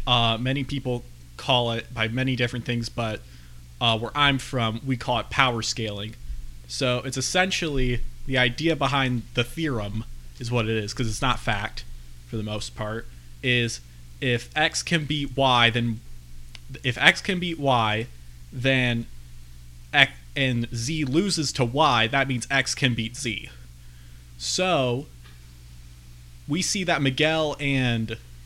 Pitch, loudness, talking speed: 120 Hz, -24 LUFS, 150 wpm